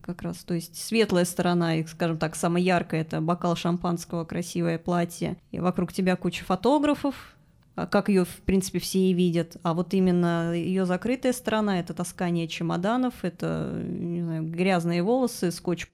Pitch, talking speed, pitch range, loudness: 175 Hz, 160 wpm, 170-190 Hz, -26 LUFS